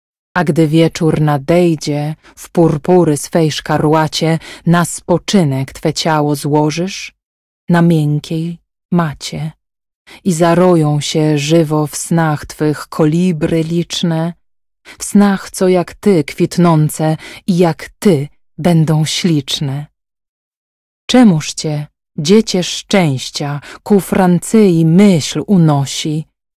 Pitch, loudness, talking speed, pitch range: 165 Hz, -13 LUFS, 100 wpm, 150-180 Hz